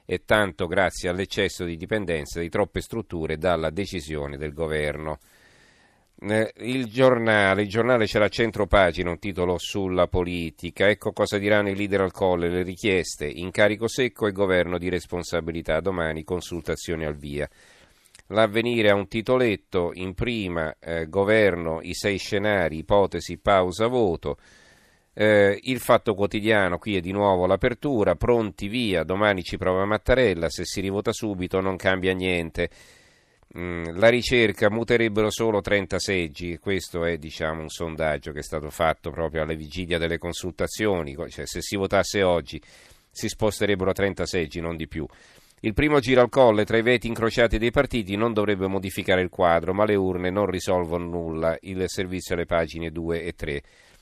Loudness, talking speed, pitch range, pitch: -24 LUFS, 155 wpm, 85-105 Hz, 95 Hz